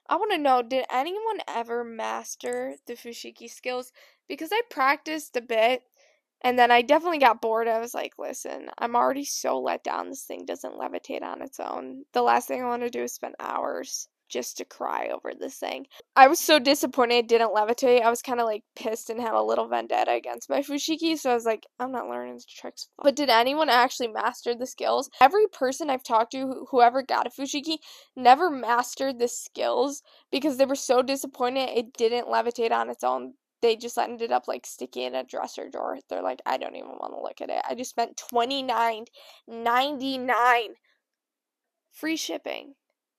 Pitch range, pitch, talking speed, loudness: 230-280 Hz, 250 Hz, 205 wpm, -25 LUFS